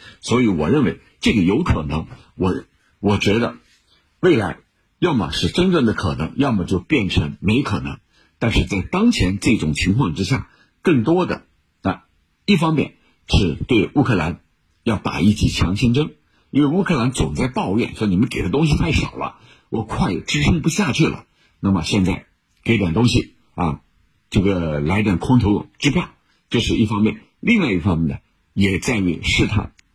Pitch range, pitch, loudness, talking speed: 90-115 Hz, 100 Hz, -19 LUFS, 245 characters per minute